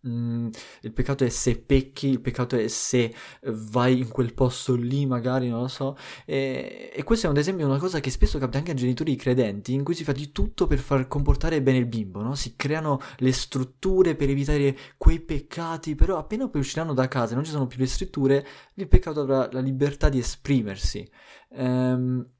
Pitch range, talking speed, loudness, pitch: 125-145 Hz, 210 wpm, -25 LUFS, 130 Hz